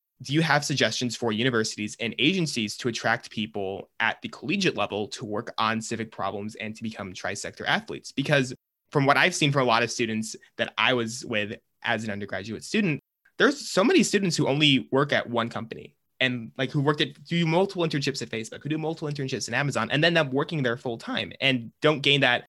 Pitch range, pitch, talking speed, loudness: 110-150 Hz, 125 Hz, 215 wpm, -25 LUFS